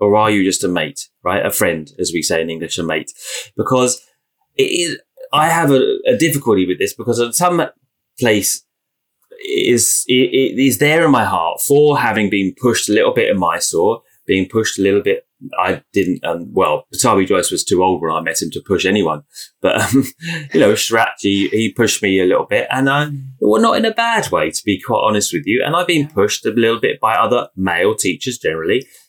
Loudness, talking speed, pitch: -15 LUFS, 225 wpm, 145 Hz